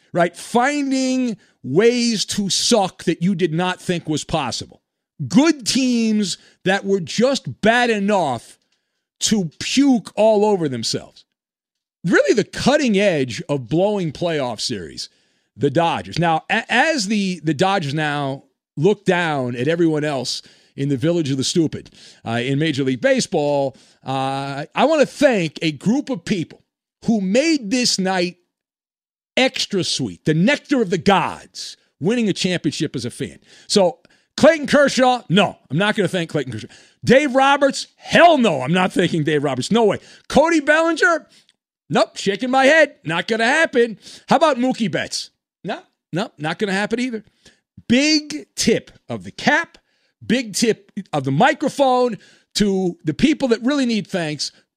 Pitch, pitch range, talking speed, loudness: 200 Hz, 160-250 Hz, 155 wpm, -18 LUFS